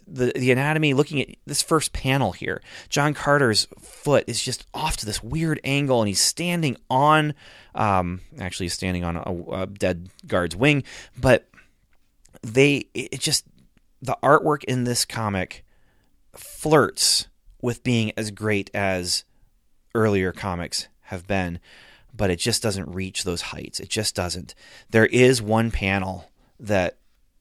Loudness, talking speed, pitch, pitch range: -23 LUFS, 145 wpm, 110 Hz, 95-135 Hz